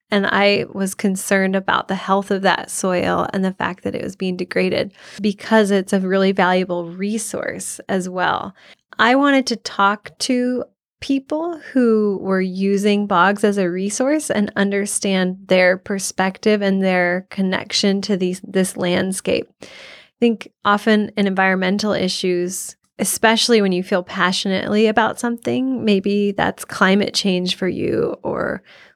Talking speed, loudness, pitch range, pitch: 145 wpm, -18 LUFS, 190-215 Hz, 200 Hz